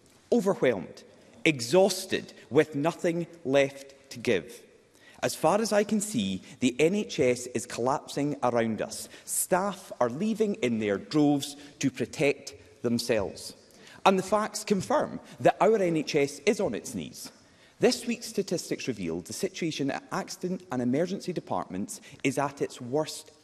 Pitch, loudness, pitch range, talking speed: 155 Hz, -28 LUFS, 135-195 Hz, 140 wpm